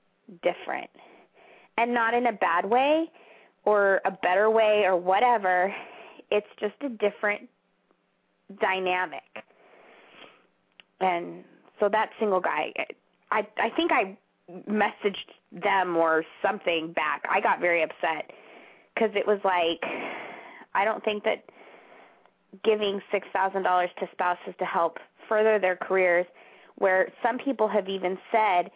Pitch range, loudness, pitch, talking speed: 185-215 Hz, -26 LUFS, 195 Hz, 125 wpm